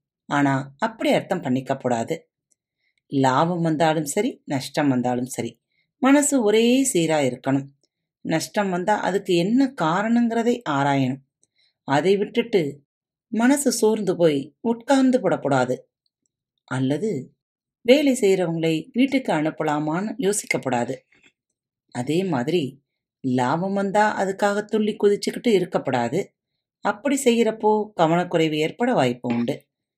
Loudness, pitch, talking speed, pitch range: -22 LUFS, 175 Hz, 95 wpm, 140-215 Hz